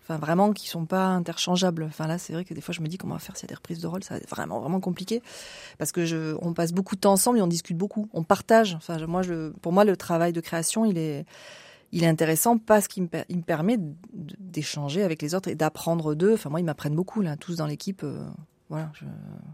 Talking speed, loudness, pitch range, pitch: 260 wpm, -26 LUFS, 160-195 Hz, 170 Hz